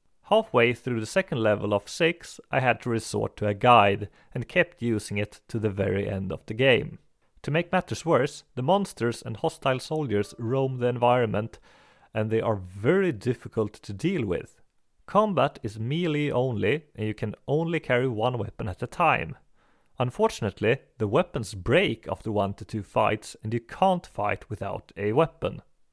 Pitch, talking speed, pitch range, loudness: 120 Hz, 175 wpm, 105-145 Hz, -26 LUFS